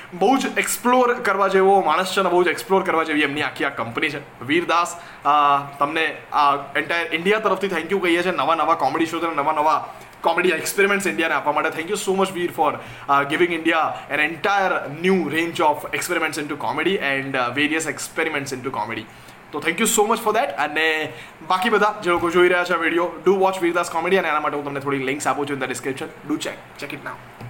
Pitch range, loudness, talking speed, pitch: 145-190 Hz, -20 LUFS, 215 wpm, 165 Hz